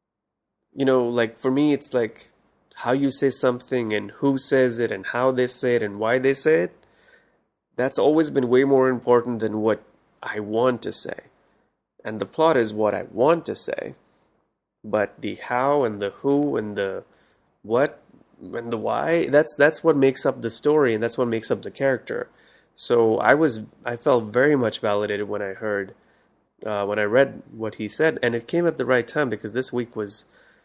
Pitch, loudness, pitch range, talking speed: 120 Hz, -22 LUFS, 110-135 Hz, 195 wpm